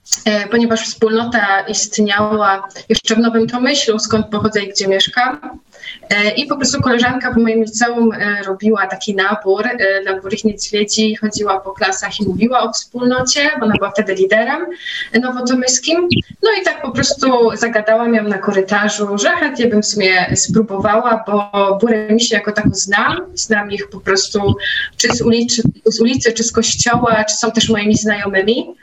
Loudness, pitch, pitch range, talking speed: -14 LUFS, 220 Hz, 205-240 Hz, 160 wpm